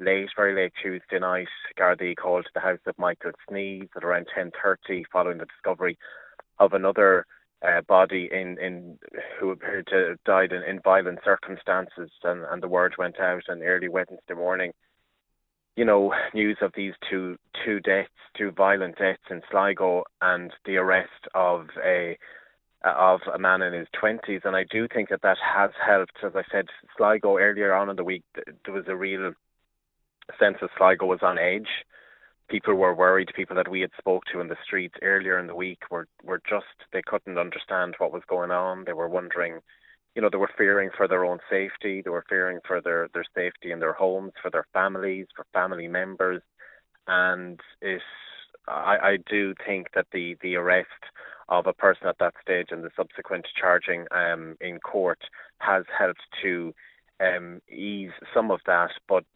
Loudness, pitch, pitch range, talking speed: -25 LUFS, 95 Hz, 90-95 Hz, 185 wpm